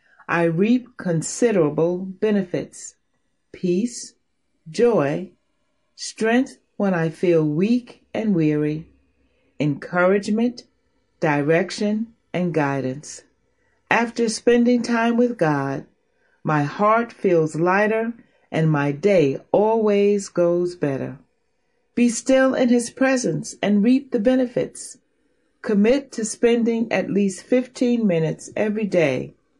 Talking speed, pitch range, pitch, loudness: 100 wpm, 165-240 Hz, 210 Hz, -21 LUFS